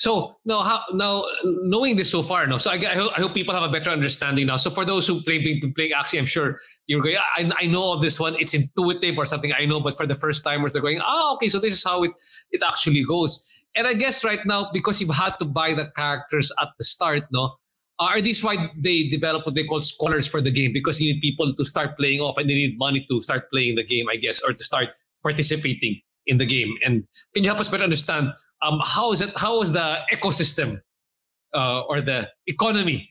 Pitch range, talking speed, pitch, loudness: 145-190 Hz, 250 wpm, 155 Hz, -22 LUFS